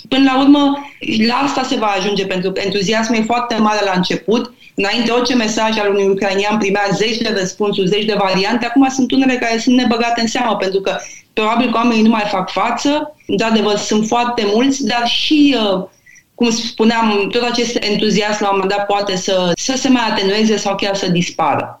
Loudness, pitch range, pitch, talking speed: -15 LUFS, 200-240 Hz, 220 Hz, 195 wpm